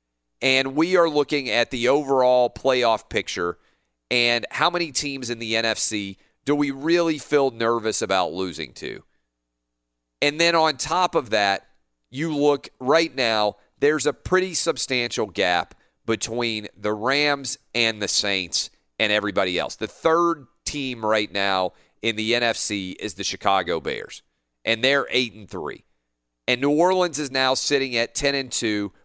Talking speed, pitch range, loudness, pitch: 155 wpm, 100-145 Hz, -22 LUFS, 120 Hz